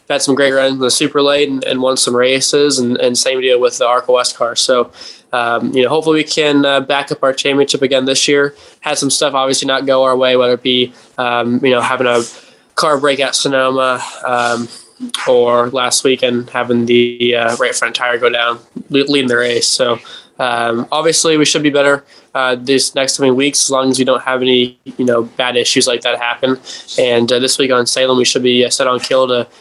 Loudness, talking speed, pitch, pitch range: -13 LUFS, 225 wpm, 130 Hz, 120-140 Hz